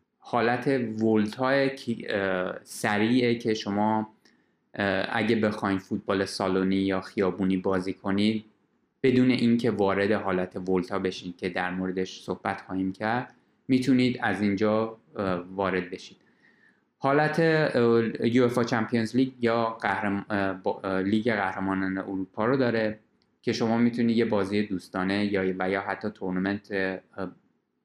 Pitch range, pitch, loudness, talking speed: 95-115 Hz, 105 Hz, -27 LUFS, 110 wpm